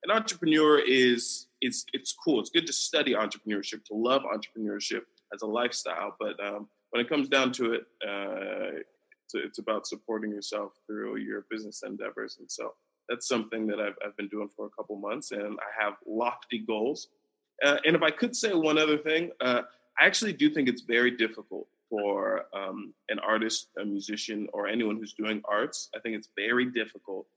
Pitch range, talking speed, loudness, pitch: 105-155 Hz, 190 wpm, -29 LUFS, 120 Hz